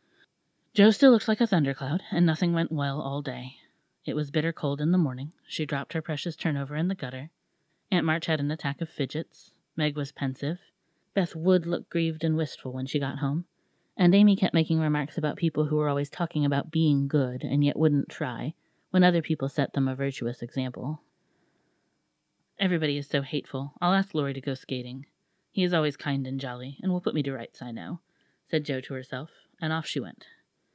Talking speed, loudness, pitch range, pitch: 205 wpm, -28 LUFS, 140-170 Hz, 150 Hz